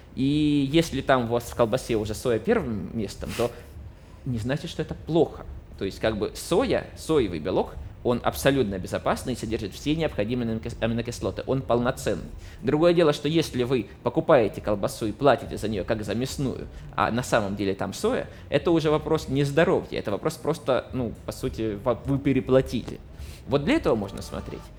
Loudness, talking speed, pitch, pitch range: -26 LUFS, 175 wpm, 120 Hz, 100-140 Hz